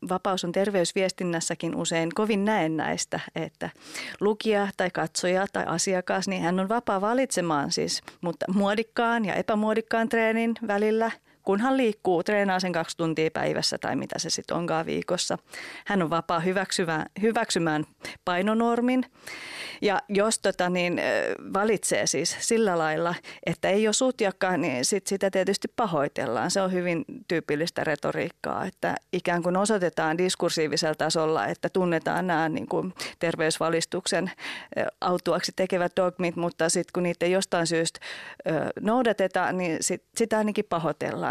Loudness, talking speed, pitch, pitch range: -26 LUFS, 135 wpm, 185 Hz, 170-210 Hz